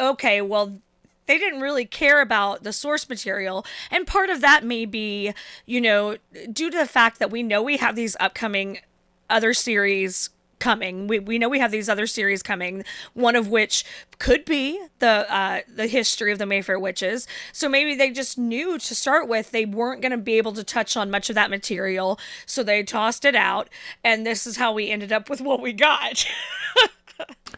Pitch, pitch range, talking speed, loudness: 225 Hz, 205-265 Hz, 200 wpm, -21 LUFS